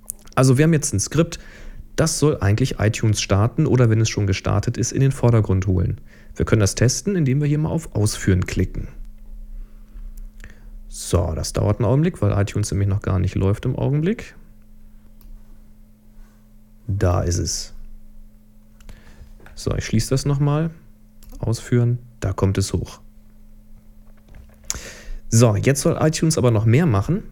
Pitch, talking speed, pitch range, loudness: 110 Hz, 150 wpm, 105-125 Hz, -20 LUFS